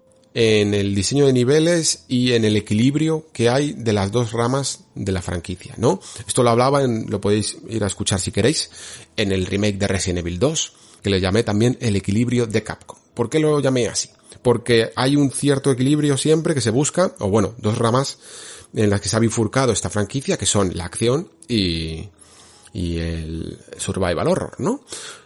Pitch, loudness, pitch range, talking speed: 115 Hz, -20 LUFS, 100-135 Hz, 190 wpm